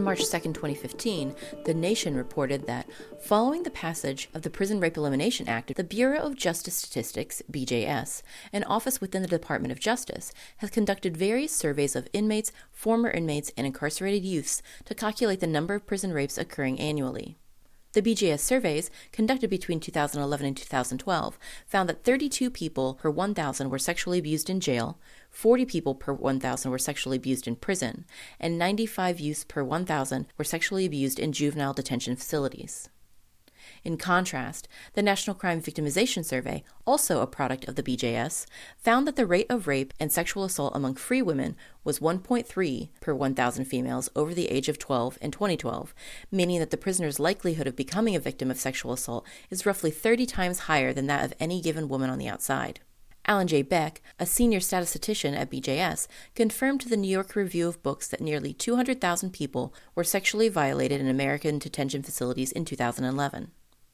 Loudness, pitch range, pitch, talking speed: -28 LUFS, 140-200 Hz, 165 Hz, 170 wpm